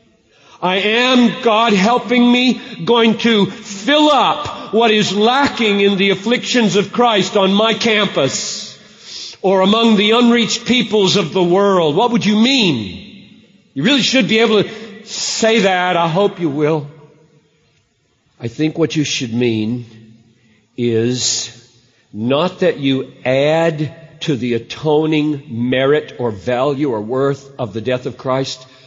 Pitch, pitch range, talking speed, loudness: 185 Hz, 135-220 Hz, 140 wpm, -14 LUFS